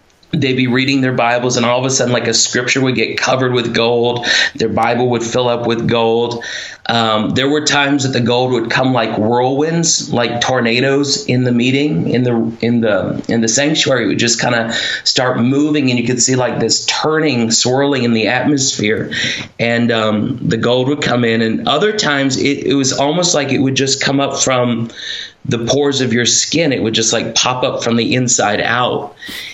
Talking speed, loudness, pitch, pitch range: 205 wpm, -14 LUFS, 125 Hz, 115-135 Hz